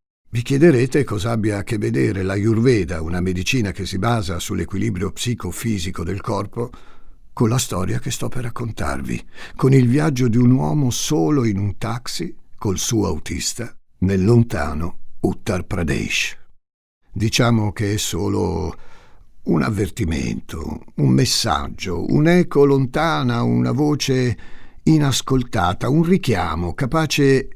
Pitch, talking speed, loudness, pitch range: 115 Hz, 130 wpm, -19 LUFS, 95-130 Hz